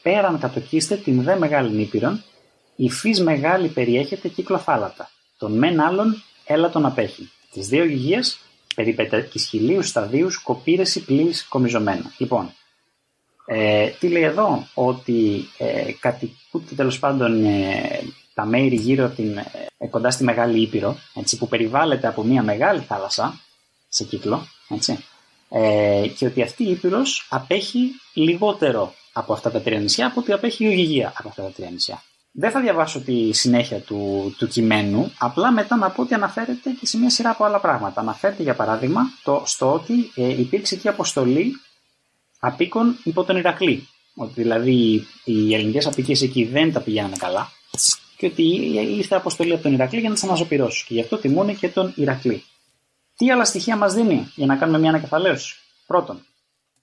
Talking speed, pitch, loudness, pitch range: 165 wpm, 140 Hz, -20 LUFS, 115-190 Hz